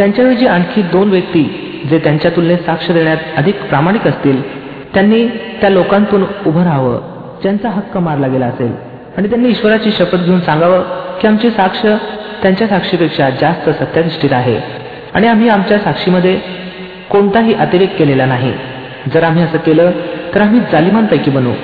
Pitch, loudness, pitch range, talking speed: 180 Hz, -12 LUFS, 155-200 Hz, 145 wpm